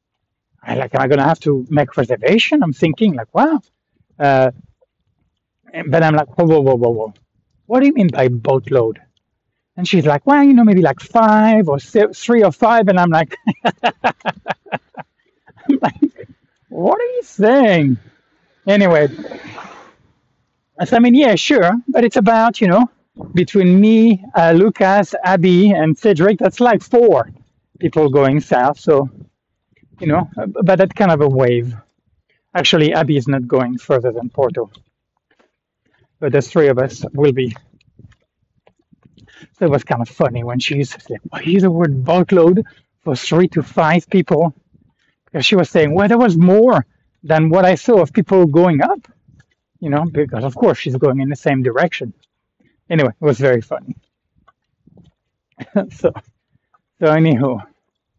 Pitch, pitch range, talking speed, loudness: 165 Hz, 135-200 Hz, 160 wpm, -14 LUFS